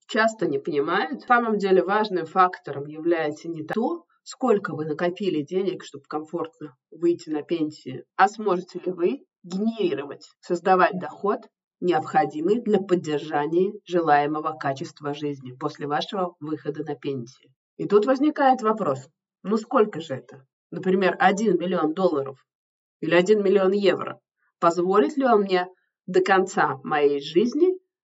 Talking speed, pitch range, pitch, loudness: 135 wpm, 155-210 Hz, 180 Hz, -24 LUFS